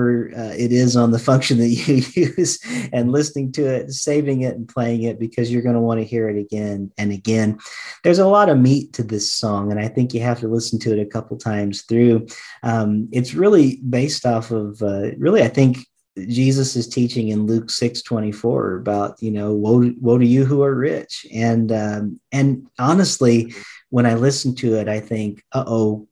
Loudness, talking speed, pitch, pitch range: -18 LUFS, 205 wpm, 120 Hz, 110-130 Hz